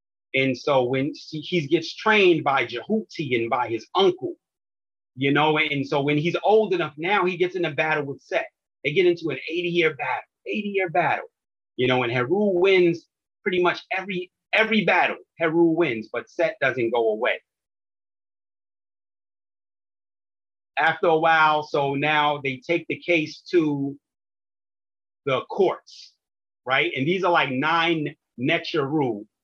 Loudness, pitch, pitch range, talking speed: -23 LUFS, 150 Hz, 115-175 Hz, 145 wpm